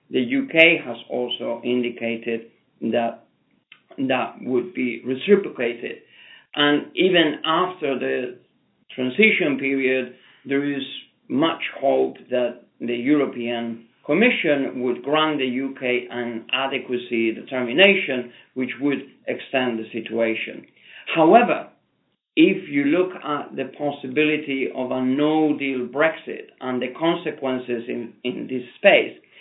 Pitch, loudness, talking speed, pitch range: 130 Hz, -21 LUFS, 110 wpm, 120-155 Hz